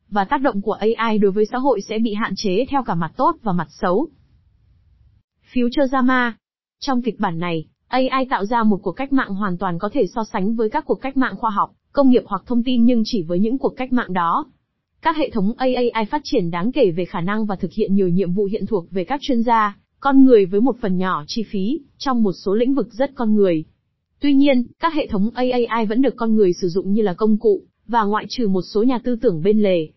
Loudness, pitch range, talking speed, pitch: -19 LUFS, 195-255 Hz, 250 wpm, 220 Hz